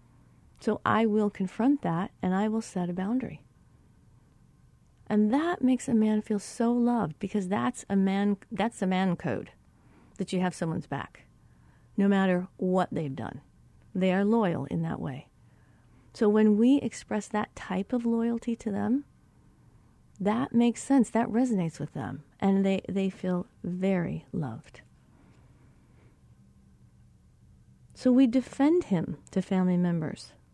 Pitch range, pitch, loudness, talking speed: 180-230 Hz, 200 Hz, -28 LUFS, 145 wpm